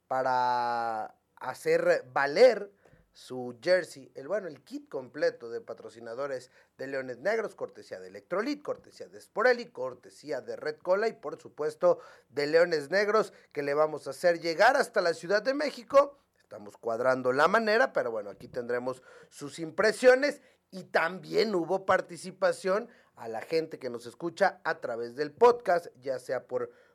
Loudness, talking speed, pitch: -29 LUFS, 155 wpm, 205 Hz